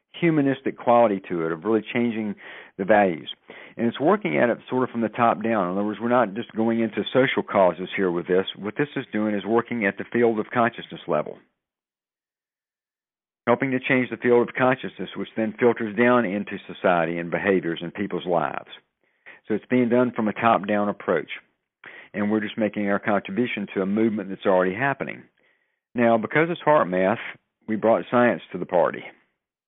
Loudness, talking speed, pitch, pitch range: -23 LUFS, 190 wpm, 110 Hz, 100-120 Hz